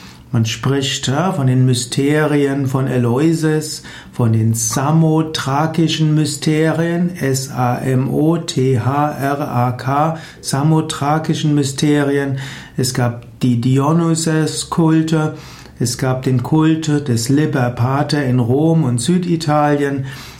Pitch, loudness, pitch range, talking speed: 145 Hz, -16 LUFS, 130-155 Hz, 85 wpm